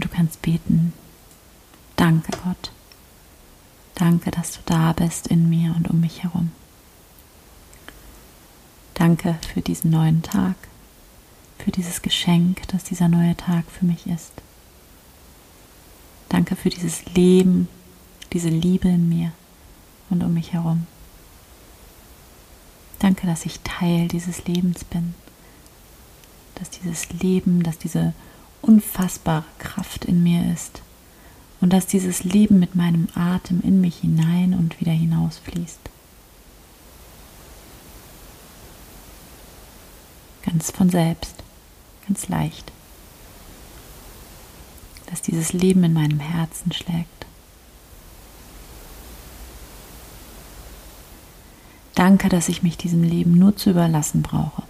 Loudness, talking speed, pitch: -20 LUFS, 105 wpm, 165 Hz